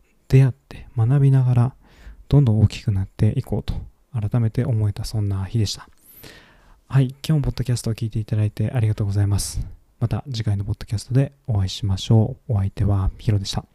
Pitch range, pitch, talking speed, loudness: 100-125 Hz, 110 Hz, 425 characters per minute, -22 LUFS